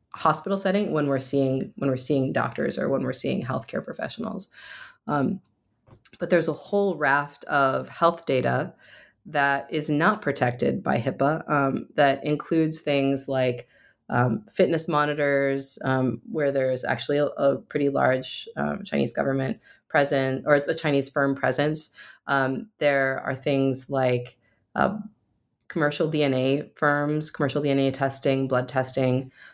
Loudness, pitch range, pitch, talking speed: -25 LUFS, 130-150 Hz, 140 Hz, 140 wpm